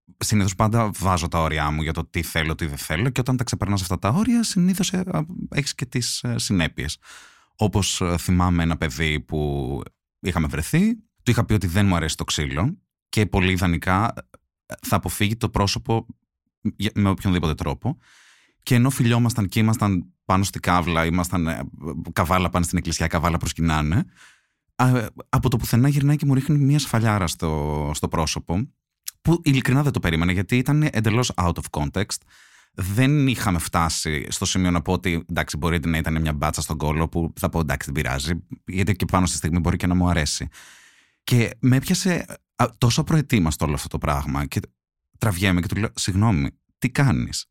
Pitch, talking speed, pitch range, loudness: 95 Hz, 175 wpm, 80-120 Hz, -22 LUFS